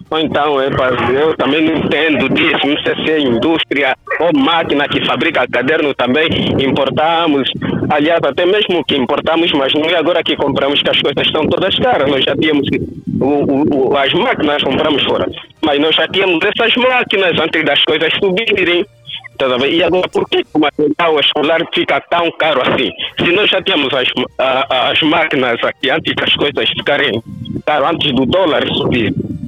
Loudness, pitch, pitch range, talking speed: -13 LUFS, 160 Hz, 145-190 Hz, 175 wpm